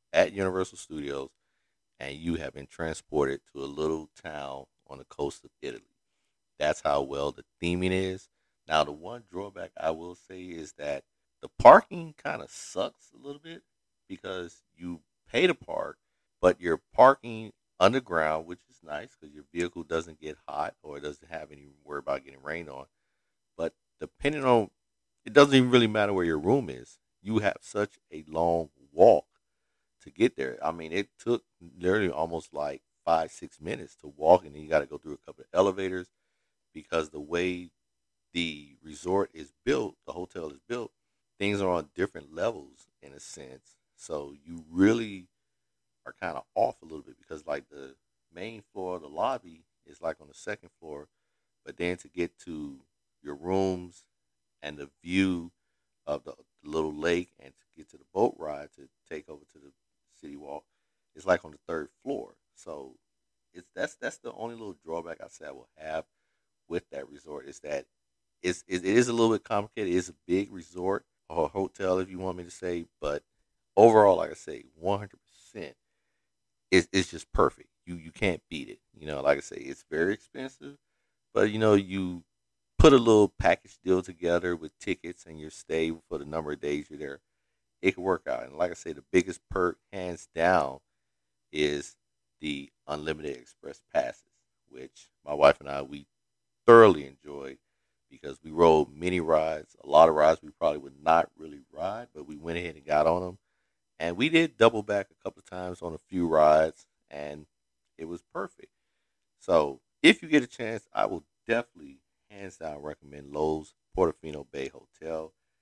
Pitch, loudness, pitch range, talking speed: 85 Hz, -27 LUFS, 75-95 Hz, 185 wpm